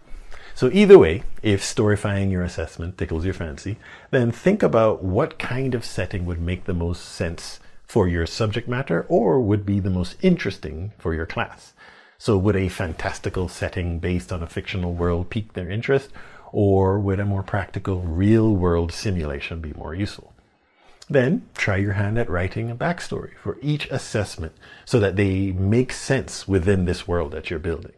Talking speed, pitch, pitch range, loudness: 175 wpm, 100 Hz, 90-110 Hz, -22 LUFS